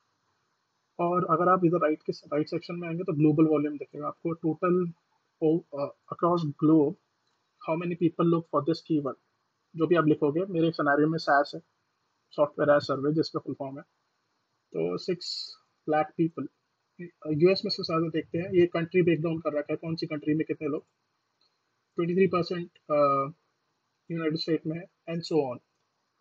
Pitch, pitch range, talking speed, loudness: 160 Hz, 150-175 Hz, 170 wpm, -28 LUFS